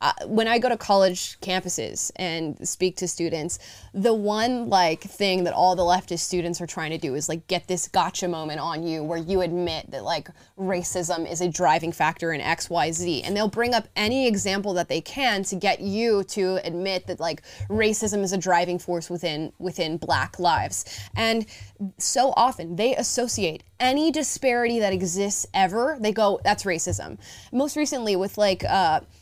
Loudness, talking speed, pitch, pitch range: -24 LUFS, 185 wpm, 185 Hz, 170-210 Hz